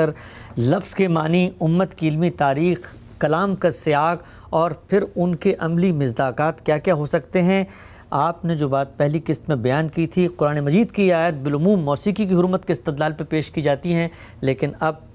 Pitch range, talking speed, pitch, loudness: 145-180 Hz, 190 wpm, 160 Hz, -21 LUFS